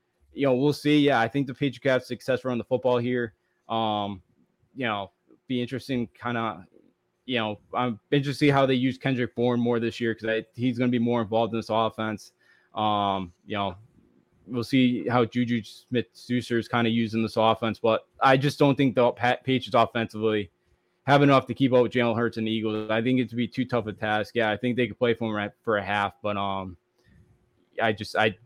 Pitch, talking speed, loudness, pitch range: 120 Hz, 220 wpm, -26 LUFS, 110-125 Hz